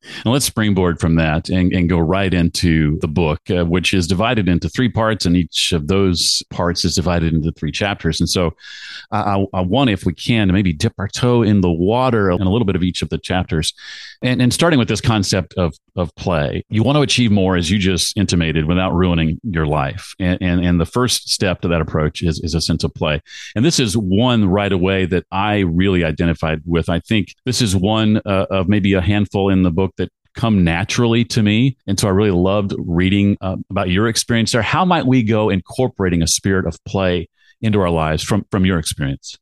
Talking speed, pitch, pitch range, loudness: 225 wpm, 95 Hz, 85-110 Hz, -17 LUFS